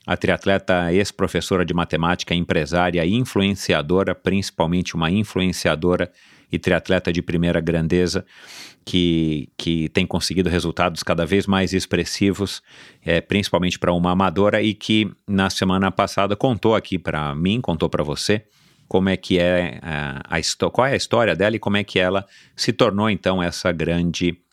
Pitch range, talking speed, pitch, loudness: 85-95 Hz, 155 wpm, 90 Hz, -20 LUFS